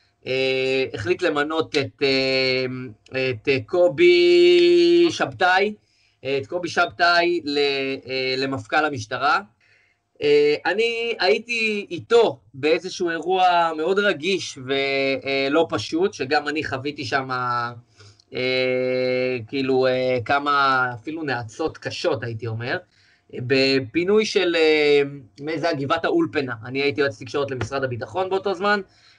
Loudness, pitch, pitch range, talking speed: -21 LUFS, 140 Hz, 130-175 Hz, 115 wpm